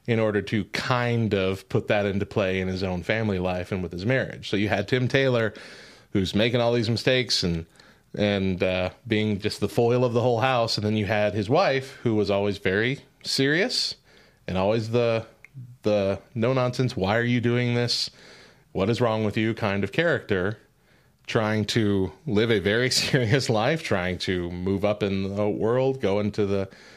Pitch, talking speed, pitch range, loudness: 110 Hz, 190 wpm, 100-120 Hz, -24 LUFS